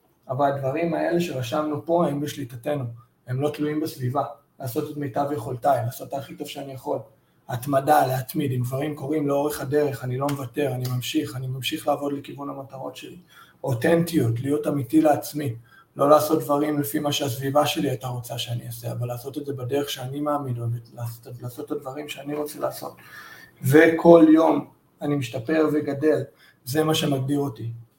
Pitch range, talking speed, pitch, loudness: 130-150 Hz, 165 wpm, 145 Hz, -24 LUFS